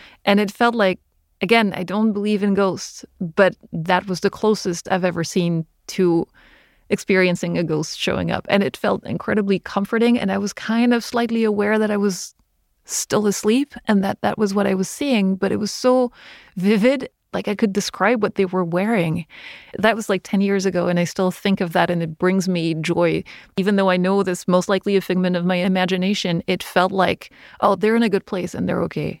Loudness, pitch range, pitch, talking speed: -20 LUFS, 180-210 Hz, 195 Hz, 210 wpm